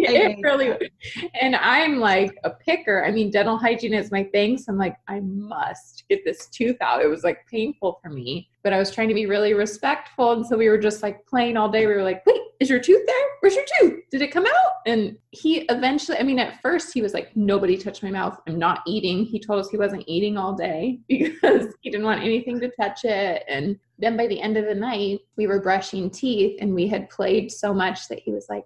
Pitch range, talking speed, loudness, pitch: 200-255 Hz, 245 wpm, -22 LUFS, 215 Hz